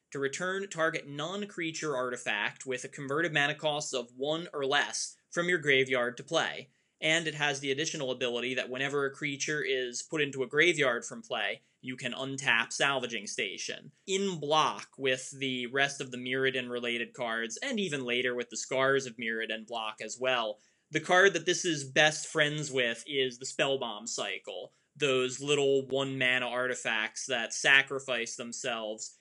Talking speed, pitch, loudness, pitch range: 170 wpm, 135 Hz, -30 LUFS, 125-155 Hz